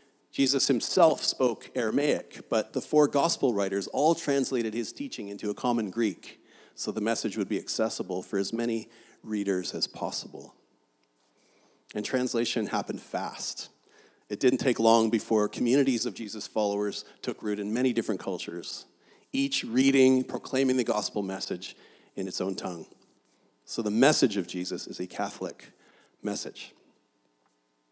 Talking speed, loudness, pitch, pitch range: 145 wpm, -28 LUFS, 110 Hz, 100-130 Hz